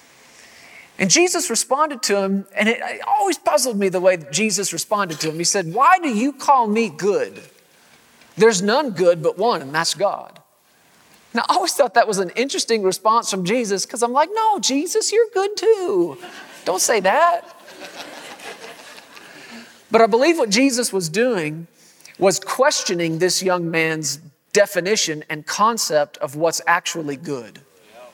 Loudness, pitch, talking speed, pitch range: -18 LUFS, 215 Hz, 160 wpm, 175-280 Hz